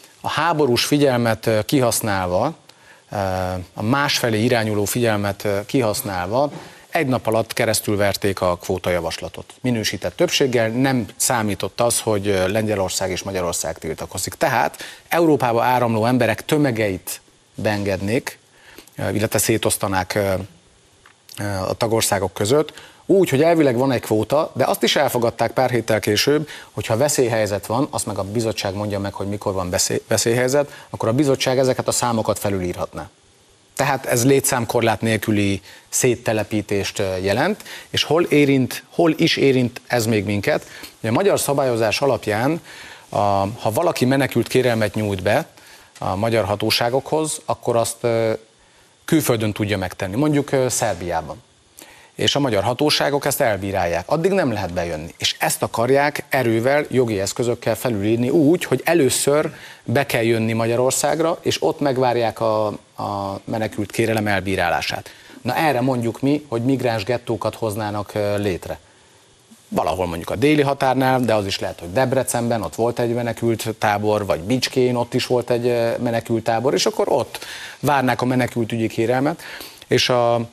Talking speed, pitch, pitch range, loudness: 135 wpm, 115 Hz, 105-130 Hz, -20 LUFS